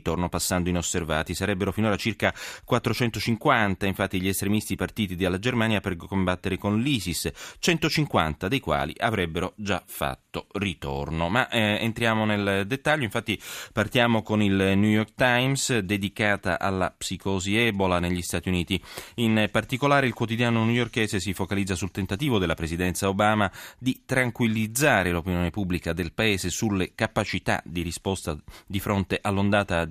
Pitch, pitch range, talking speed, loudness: 100 Hz, 90-110 Hz, 140 wpm, -25 LUFS